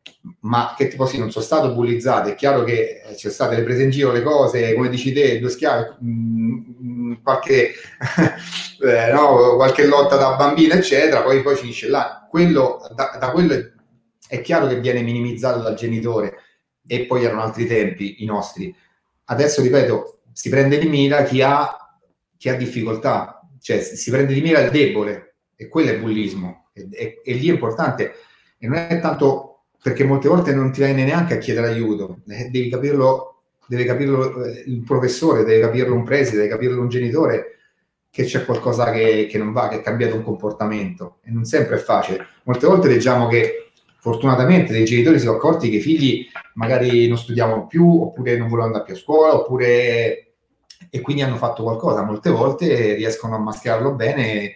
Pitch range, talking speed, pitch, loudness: 115-145 Hz, 185 wpm, 125 Hz, -18 LUFS